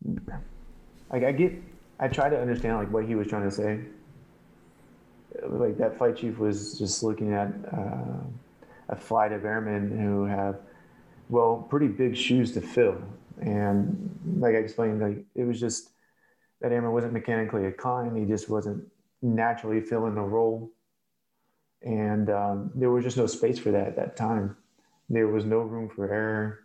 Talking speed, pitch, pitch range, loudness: 165 wpm, 110 Hz, 105-120 Hz, -28 LUFS